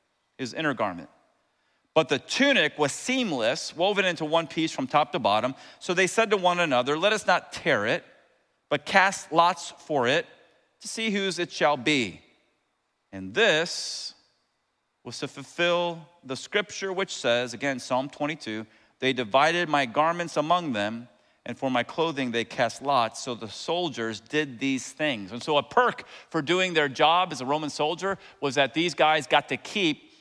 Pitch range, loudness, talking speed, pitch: 130-180 Hz, -26 LUFS, 175 wpm, 155 Hz